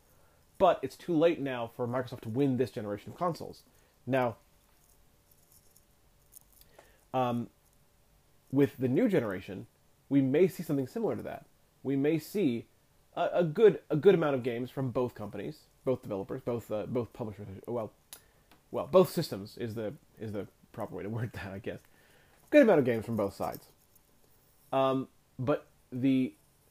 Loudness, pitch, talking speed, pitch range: -31 LUFS, 130 Hz, 160 wpm, 115-140 Hz